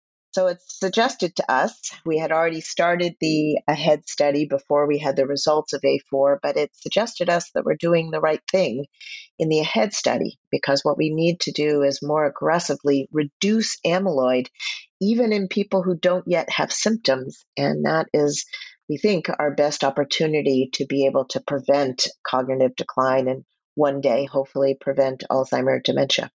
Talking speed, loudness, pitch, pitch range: 170 wpm, -22 LUFS, 150 Hz, 140-175 Hz